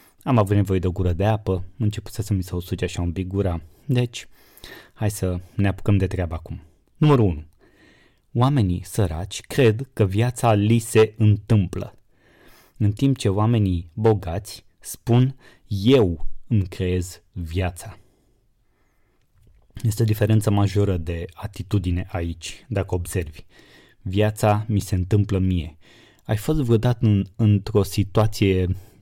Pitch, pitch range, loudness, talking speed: 100 Hz, 90-110 Hz, -22 LUFS, 140 wpm